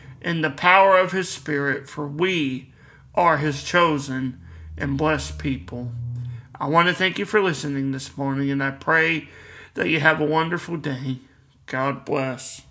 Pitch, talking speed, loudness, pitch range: 140 Hz, 160 wpm, -22 LUFS, 130-160 Hz